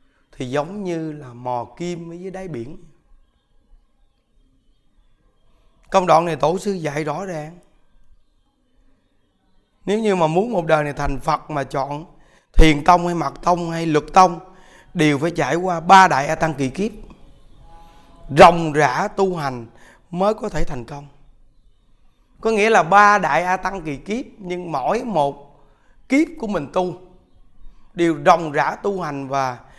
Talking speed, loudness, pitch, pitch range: 155 wpm, -18 LUFS, 165 Hz, 145-185 Hz